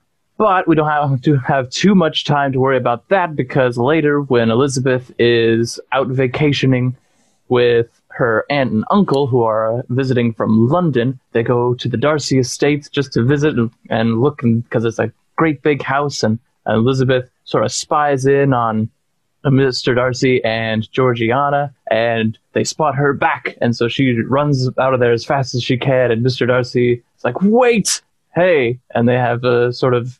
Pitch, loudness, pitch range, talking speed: 130 Hz, -16 LUFS, 120-145 Hz, 180 wpm